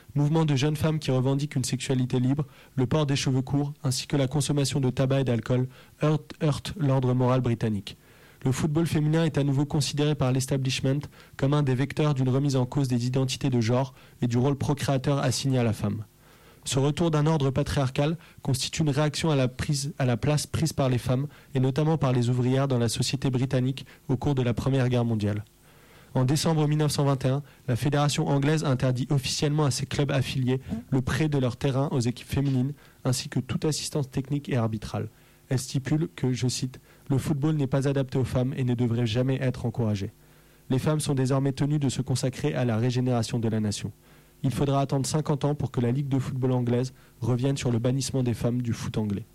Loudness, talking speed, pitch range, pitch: -26 LUFS, 205 wpm, 125-145 Hz, 135 Hz